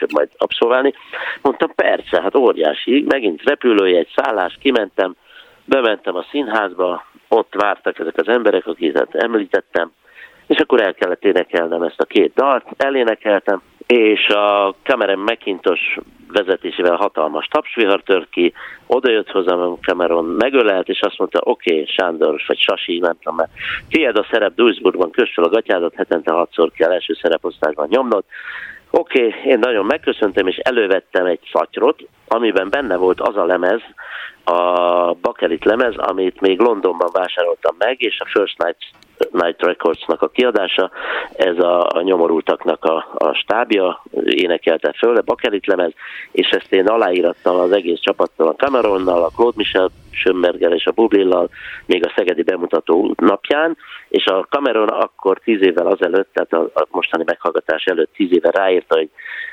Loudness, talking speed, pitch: -16 LUFS, 150 wpm, 395 Hz